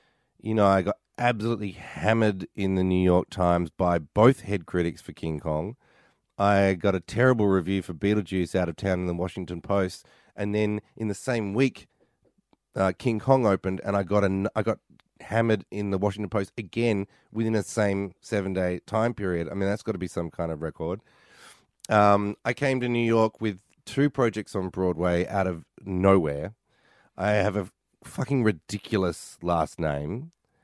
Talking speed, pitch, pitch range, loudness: 180 wpm, 100 Hz, 90-110 Hz, -26 LUFS